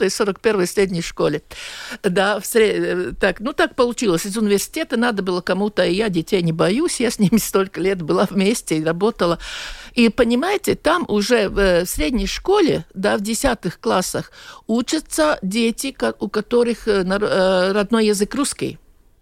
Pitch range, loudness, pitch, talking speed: 195-240 Hz, -19 LUFS, 210 Hz, 145 wpm